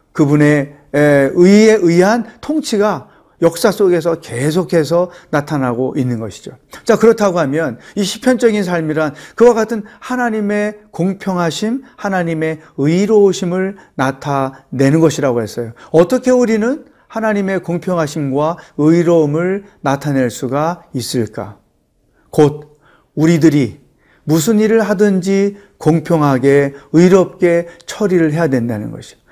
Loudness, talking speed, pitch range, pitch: -14 LUFS, 270 characters per minute, 145-205 Hz, 170 Hz